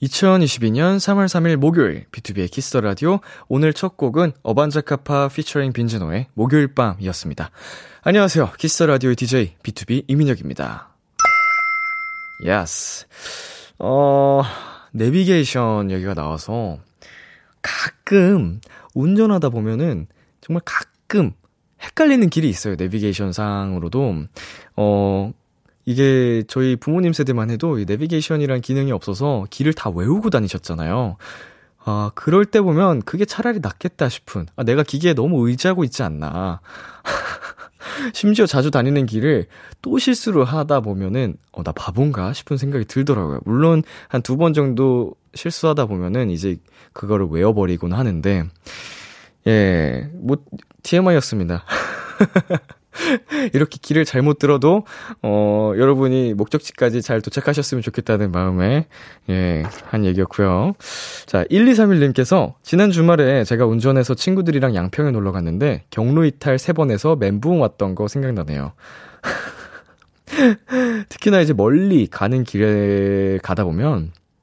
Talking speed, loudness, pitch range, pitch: 285 characters per minute, -18 LUFS, 105-165 Hz, 135 Hz